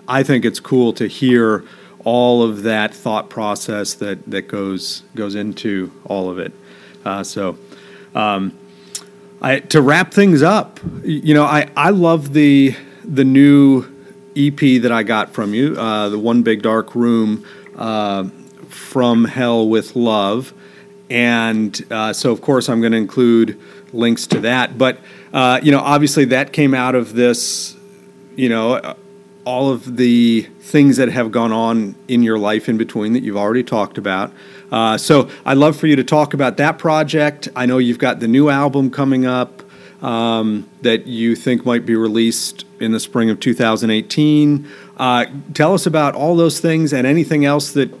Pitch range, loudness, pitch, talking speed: 115-150 Hz, -15 LUFS, 125 Hz, 170 wpm